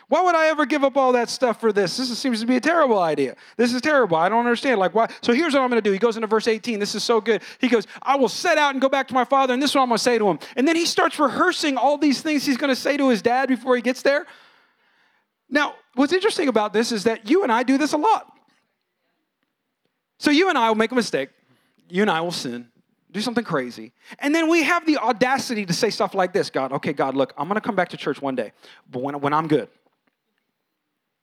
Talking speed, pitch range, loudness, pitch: 275 wpm, 210-285 Hz, -21 LUFS, 245 Hz